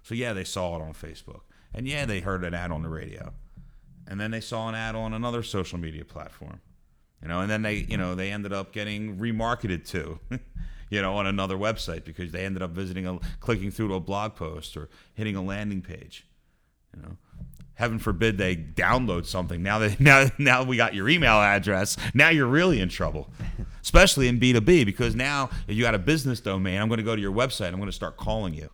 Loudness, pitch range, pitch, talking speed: -25 LUFS, 90-115 Hz, 100 Hz, 225 wpm